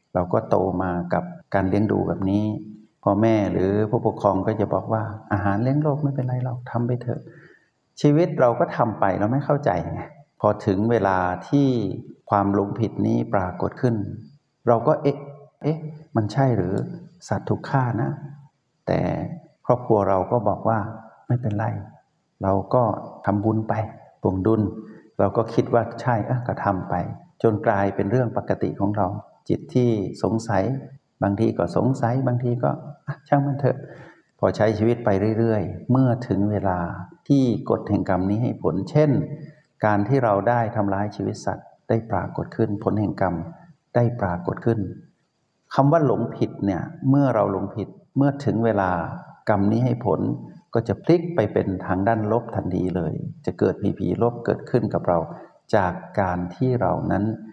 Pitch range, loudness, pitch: 100-130 Hz, -23 LUFS, 110 Hz